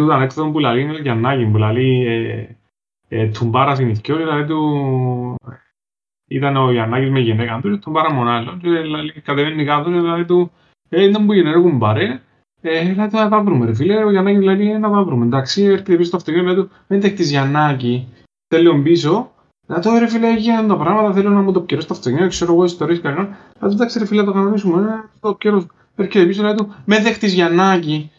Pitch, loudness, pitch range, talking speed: 170 Hz, -16 LUFS, 135-195 Hz, 65 wpm